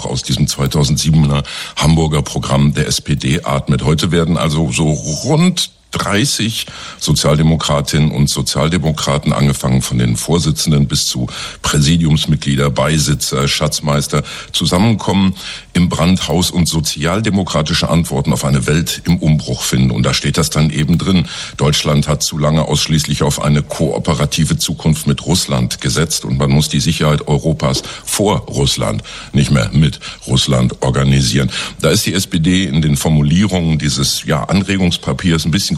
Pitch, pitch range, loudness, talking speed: 75 Hz, 70-85 Hz, -14 LUFS, 140 wpm